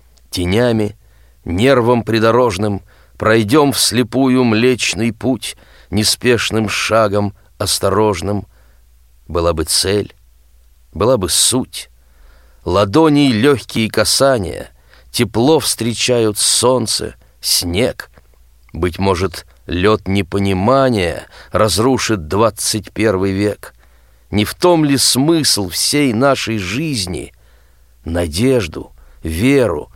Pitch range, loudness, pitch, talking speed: 75-120 Hz, -14 LUFS, 100 Hz, 80 wpm